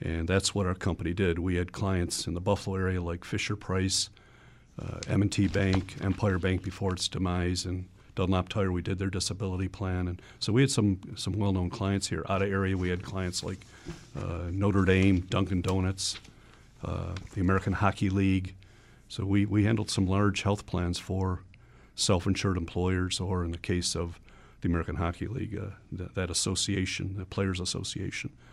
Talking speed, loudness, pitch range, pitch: 180 wpm, -30 LUFS, 90-100 Hz, 95 Hz